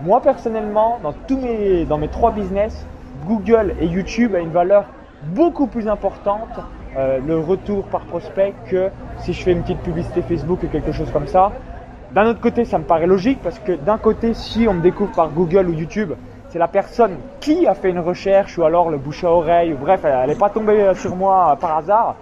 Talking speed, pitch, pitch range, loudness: 215 wpm, 190 Hz, 170-215 Hz, -18 LUFS